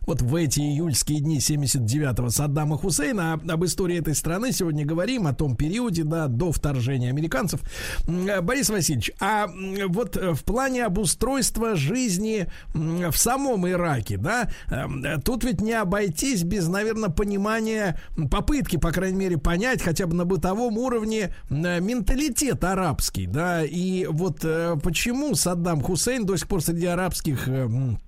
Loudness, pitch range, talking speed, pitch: -24 LUFS, 155-210 Hz, 135 wpm, 175 Hz